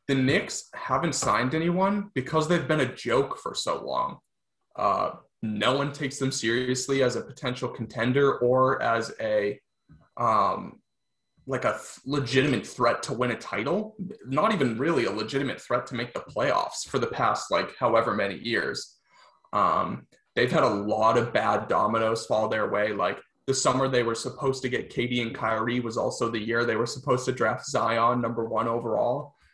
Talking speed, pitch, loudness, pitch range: 180 wpm, 125 Hz, -26 LUFS, 115-135 Hz